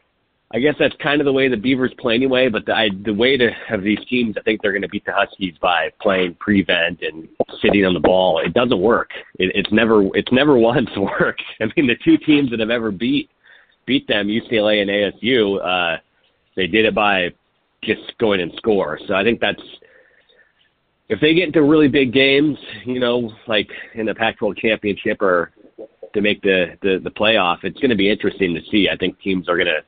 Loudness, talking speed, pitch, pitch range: -17 LUFS, 215 wpm, 110 Hz, 100-135 Hz